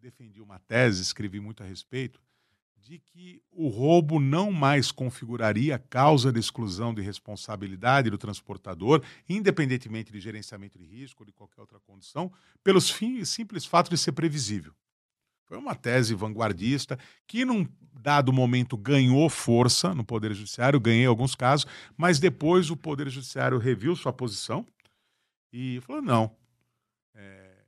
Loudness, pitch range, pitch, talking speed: -26 LUFS, 110-150 Hz, 125 Hz, 145 wpm